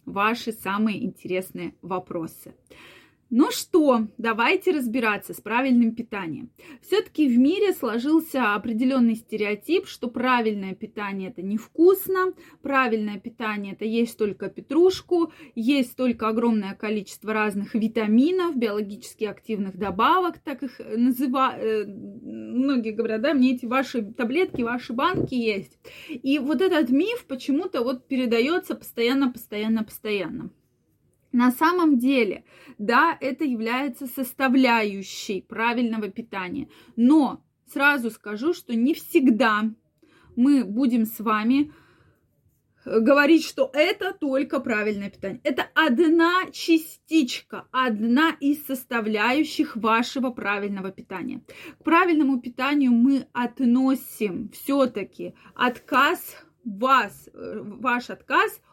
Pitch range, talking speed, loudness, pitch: 220-285 Hz, 105 wpm, -23 LUFS, 250 Hz